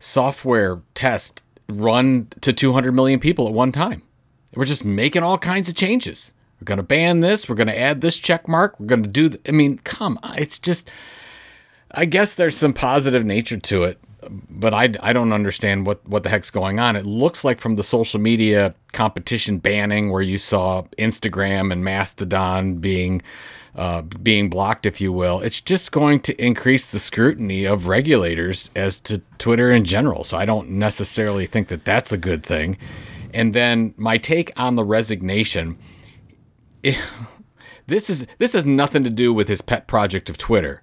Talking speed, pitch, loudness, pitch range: 180 wpm, 110 Hz, -19 LUFS, 100-130 Hz